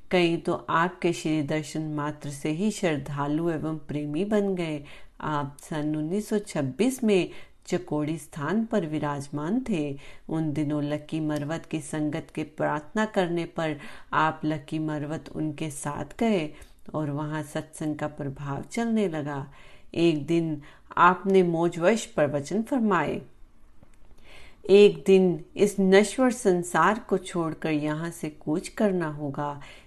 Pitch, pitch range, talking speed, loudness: 160 Hz, 150-190 Hz, 120 wpm, -27 LUFS